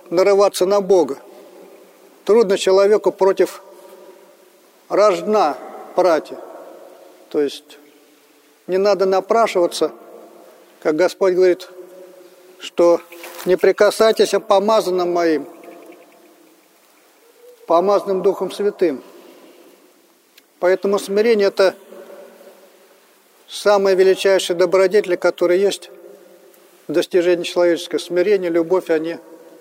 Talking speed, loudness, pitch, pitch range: 80 wpm, -17 LUFS, 185 Hz, 175-195 Hz